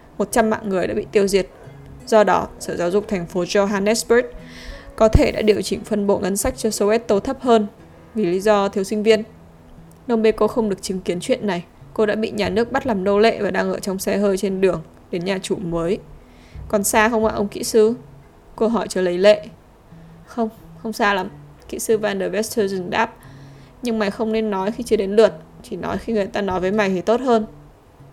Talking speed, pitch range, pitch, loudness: 225 wpm, 185-220 Hz, 205 Hz, -20 LUFS